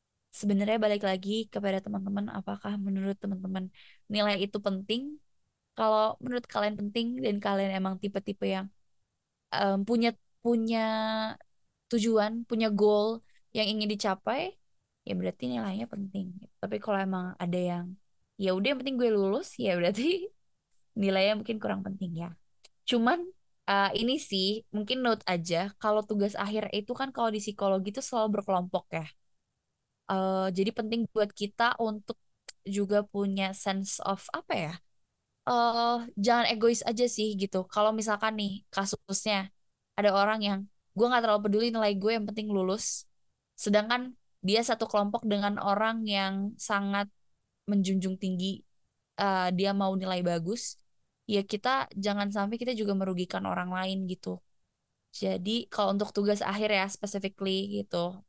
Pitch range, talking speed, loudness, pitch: 195-220 Hz, 145 wpm, -30 LUFS, 205 Hz